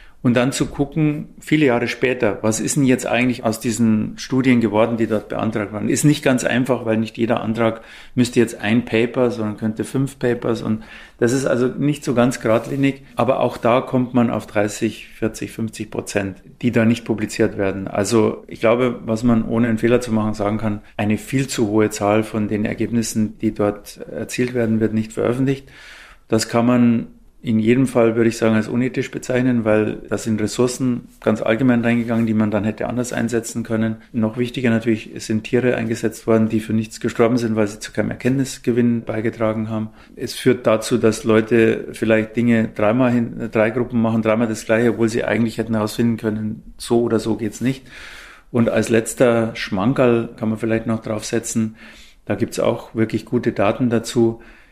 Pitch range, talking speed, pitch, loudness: 110-120 Hz, 190 wpm, 115 Hz, -19 LUFS